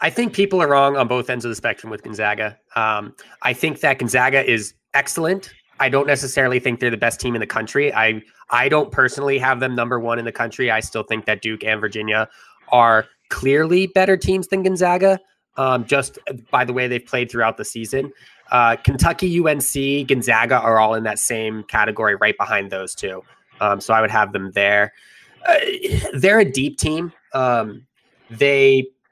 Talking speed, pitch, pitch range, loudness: 190 wpm, 125 Hz, 110-140 Hz, -18 LUFS